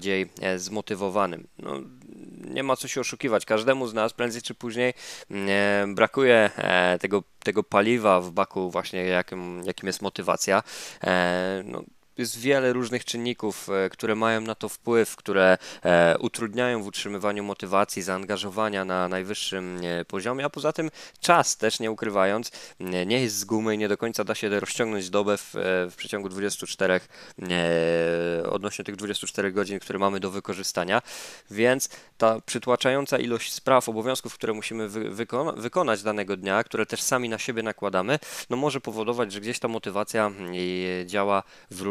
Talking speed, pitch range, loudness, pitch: 150 wpm, 95-115 Hz, -26 LUFS, 105 Hz